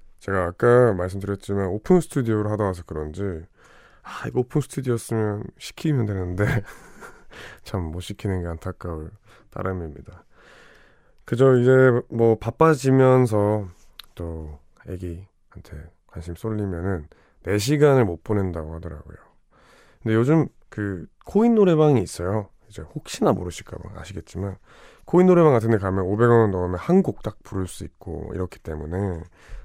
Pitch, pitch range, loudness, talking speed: 100 Hz, 90-120 Hz, -22 LUFS, 300 characters per minute